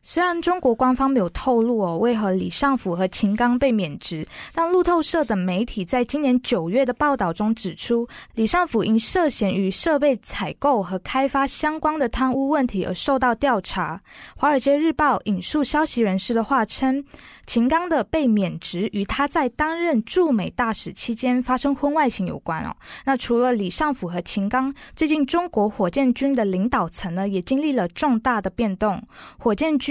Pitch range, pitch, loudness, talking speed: 210-285 Hz, 250 Hz, -21 LUFS, 275 characters per minute